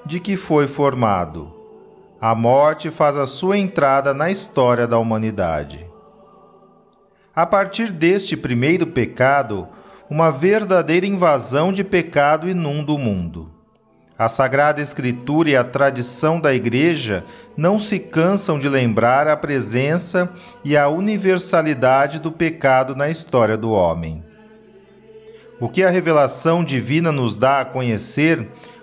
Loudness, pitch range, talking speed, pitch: -18 LUFS, 125-185 Hz, 125 wpm, 150 Hz